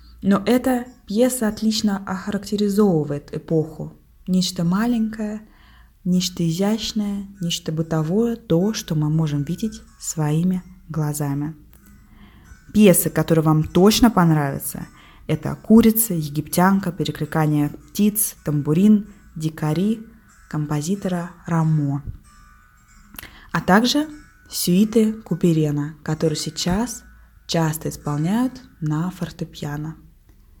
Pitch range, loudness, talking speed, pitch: 155-210 Hz, -21 LUFS, 85 wpm, 175 Hz